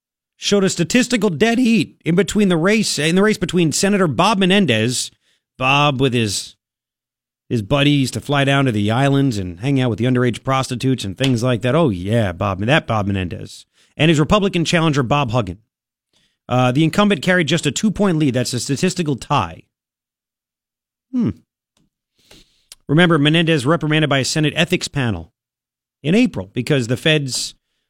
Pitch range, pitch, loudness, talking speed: 120-170 Hz, 145 Hz, -17 LUFS, 165 wpm